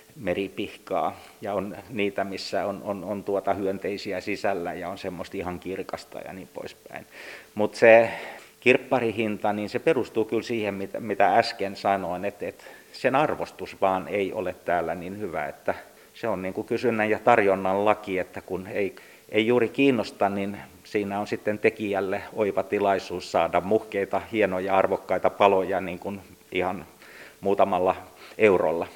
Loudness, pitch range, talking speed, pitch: -25 LUFS, 95-110 Hz, 155 wpm, 100 Hz